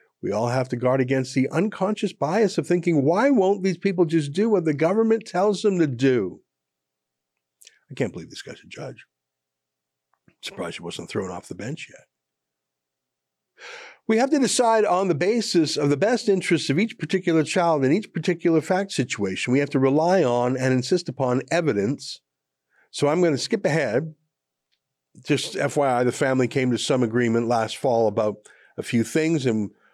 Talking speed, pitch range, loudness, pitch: 180 wpm, 110-180 Hz, -22 LUFS, 140 Hz